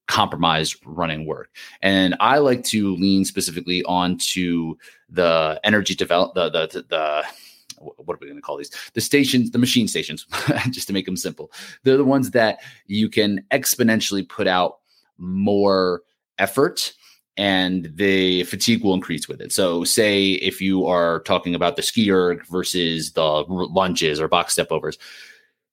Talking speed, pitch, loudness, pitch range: 155 wpm, 95 Hz, -20 LUFS, 85-100 Hz